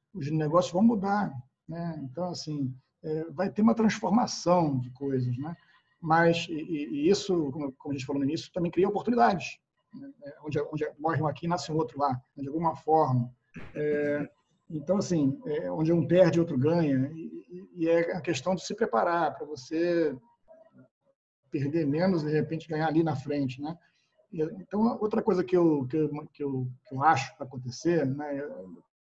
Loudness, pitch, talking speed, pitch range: -28 LUFS, 160 Hz, 180 wpm, 145-180 Hz